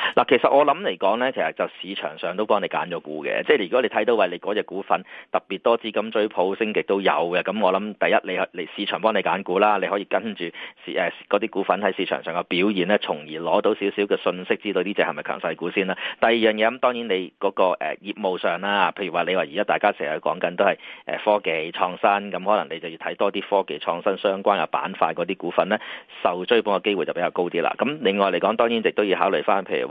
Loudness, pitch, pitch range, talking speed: -23 LUFS, 100 Hz, 100-115 Hz, 375 characters per minute